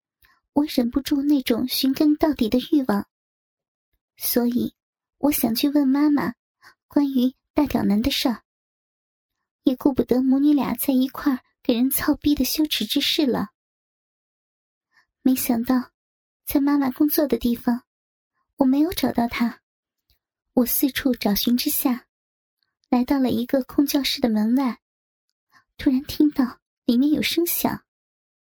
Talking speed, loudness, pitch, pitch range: 195 characters per minute, -22 LUFS, 265 Hz, 245-290 Hz